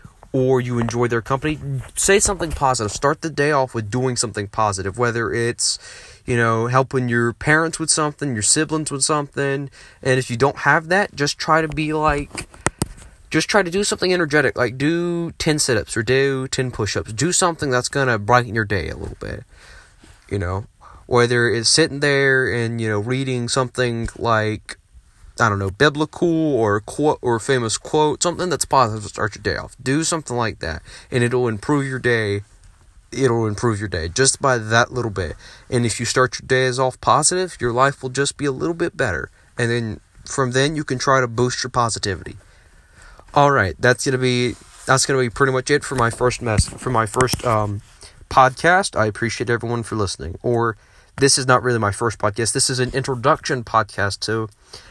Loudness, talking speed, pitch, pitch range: -19 LUFS, 200 wpm, 125 Hz, 115-140 Hz